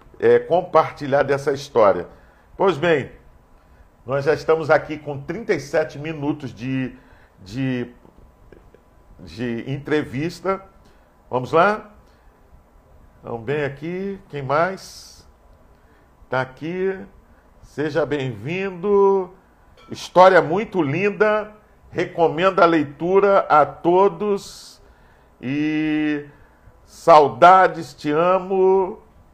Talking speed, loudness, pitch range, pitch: 80 wpm, -19 LUFS, 125-185 Hz, 150 Hz